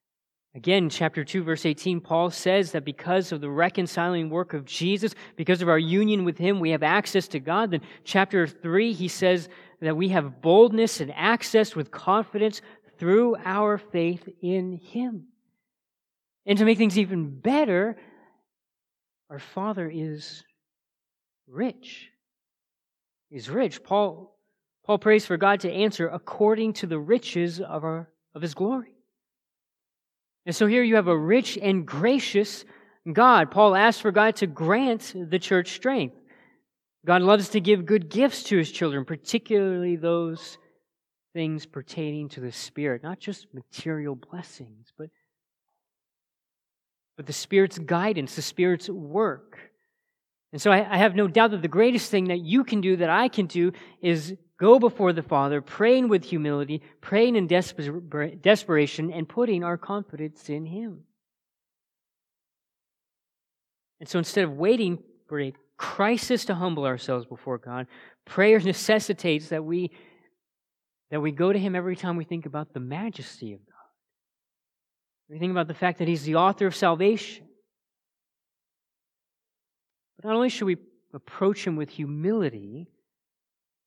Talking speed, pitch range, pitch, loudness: 145 wpm, 160-210 Hz, 180 Hz, -24 LUFS